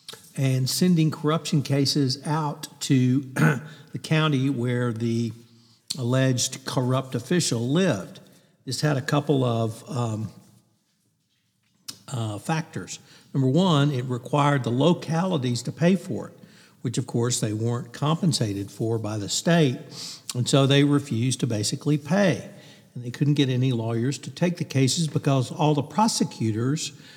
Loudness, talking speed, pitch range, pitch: -24 LUFS, 140 wpm, 120-155 Hz, 140 Hz